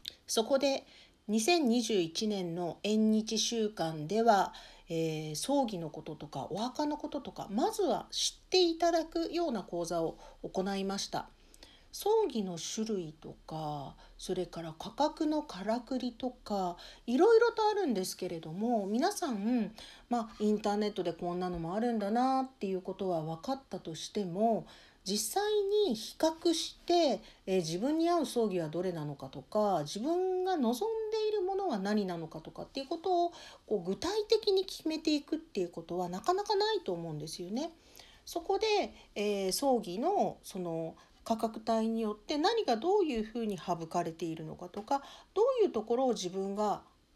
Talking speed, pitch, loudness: 315 characters per minute, 225 Hz, -33 LUFS